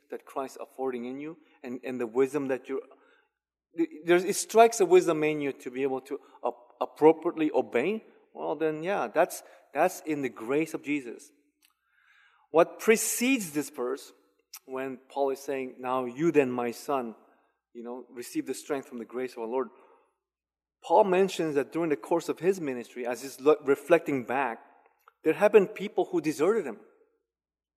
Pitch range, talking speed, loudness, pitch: 130-180 Hz, 165 wpm, -28 LUFS, 150 Hz